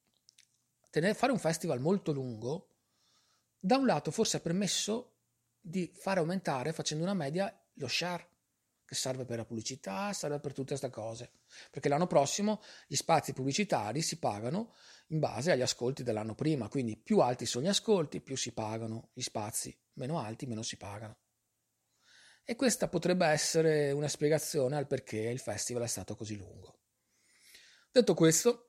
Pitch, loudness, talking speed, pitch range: 145 Hz, -33 LUFS, 155 wpm, 120-180 Hz